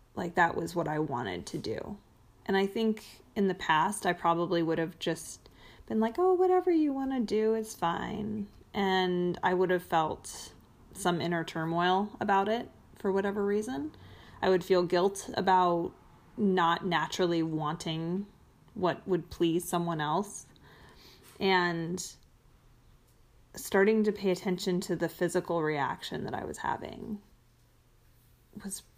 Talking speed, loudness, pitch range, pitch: 145 wpm, -30 LUFS, 165-200 Hz, 180 Hz